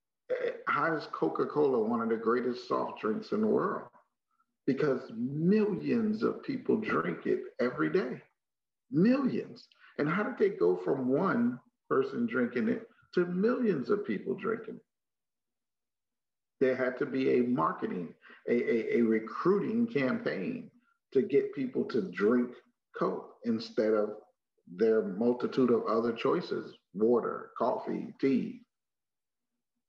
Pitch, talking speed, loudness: 220 Hz, 130 wpm, -31 LUFS